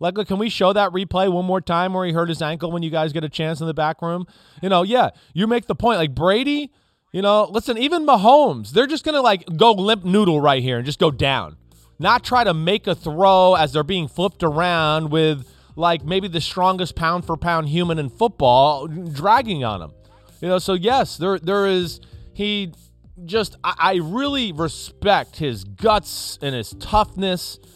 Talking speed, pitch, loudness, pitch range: 205 wpm, 175 Hz, -19 LUFS, 155-200 Hz